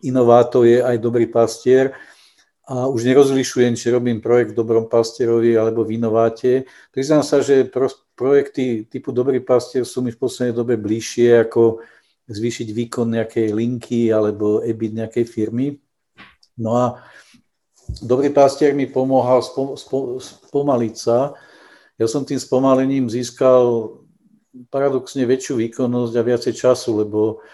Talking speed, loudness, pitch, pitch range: 130 wpm, -18 LUFS, 120 Hz, 115-130 Hz